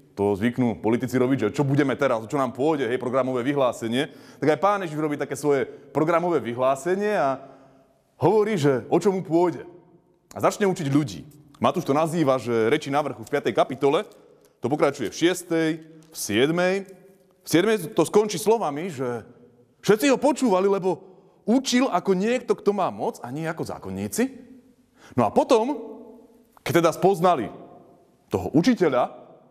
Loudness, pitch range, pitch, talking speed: -23 LUFS, 135-195 Hz, 160 Hz, 155 wpm